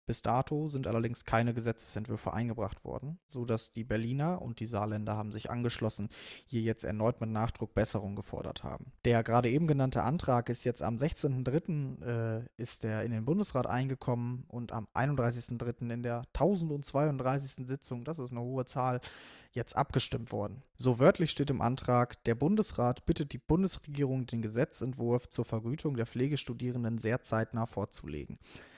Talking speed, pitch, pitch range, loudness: 155 wpm, 120 Hz, 115-135 Hz, -33 LUFS